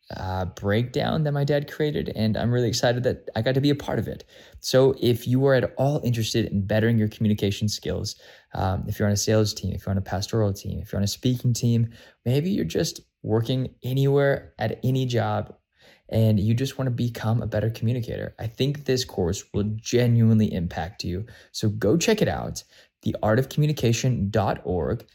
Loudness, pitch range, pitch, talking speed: -24 LUFS, 105-130 Hz, 115 Hz, 195 wpm